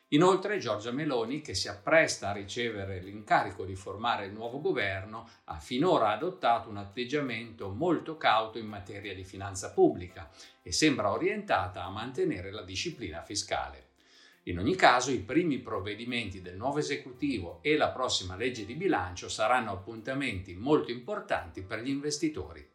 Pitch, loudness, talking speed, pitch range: 115 Hz, -31 LUFS, 150 wpm, 100-130 Hz